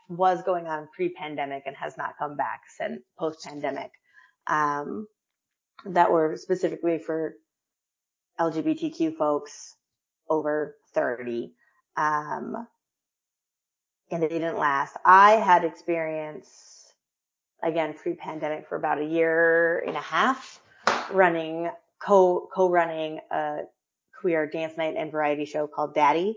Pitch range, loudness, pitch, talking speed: 150-180 Hz, -25 LUFS, 165 Hz, 110 wpm